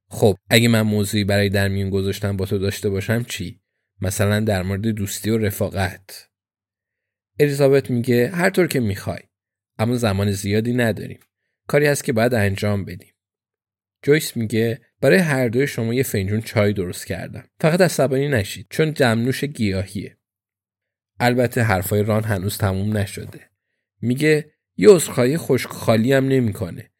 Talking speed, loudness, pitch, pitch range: 140 wpm, -20 LUFS, 110 Hz, 100-125 Hz